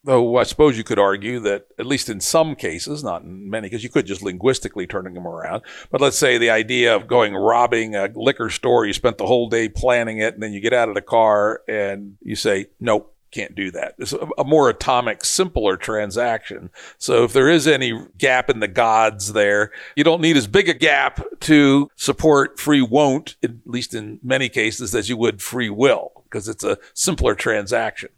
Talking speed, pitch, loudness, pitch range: 210 wpm, 115 Hz, -18 LUFS, 105-140 Hz